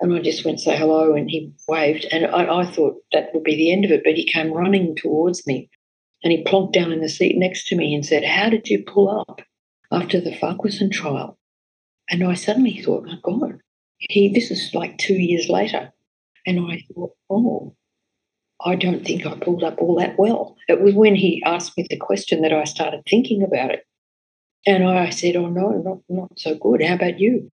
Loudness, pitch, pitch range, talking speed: -19 LUFS, 175 Hz, 160-195 Hz, 220 wpm